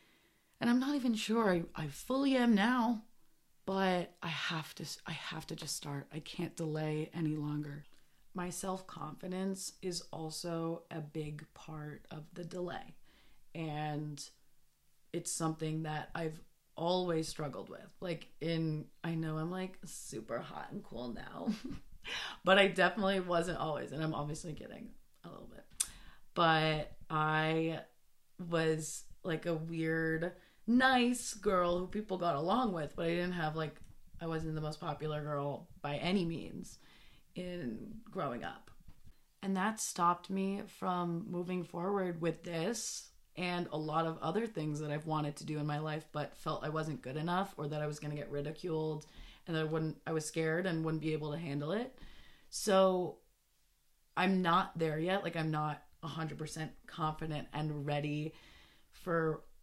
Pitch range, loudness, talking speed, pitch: 155-185 Hz, -37 LUFS, 160 wpm, 165 Hz